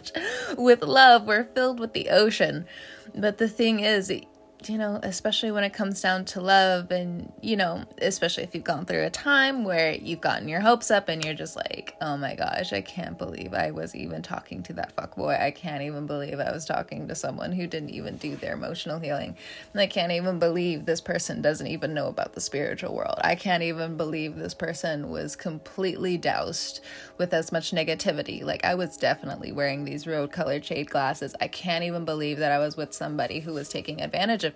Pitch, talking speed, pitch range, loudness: 175 Hz, 210 wpm, 155-210 Hz, -26 LUFS